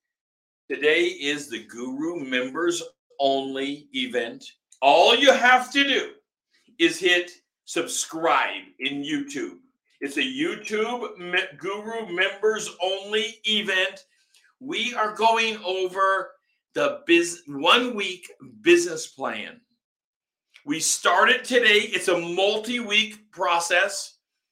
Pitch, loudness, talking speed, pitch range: 220 Hz, -22 LUFS, 105 wpm, 185-275 Hz